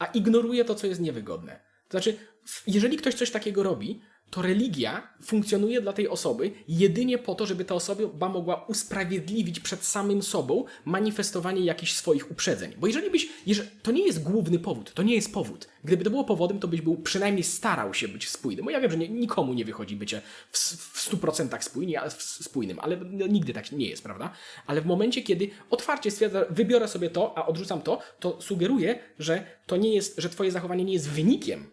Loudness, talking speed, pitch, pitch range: -27 LUFS, 200 wpm, 195 Hz, 175-220 Hz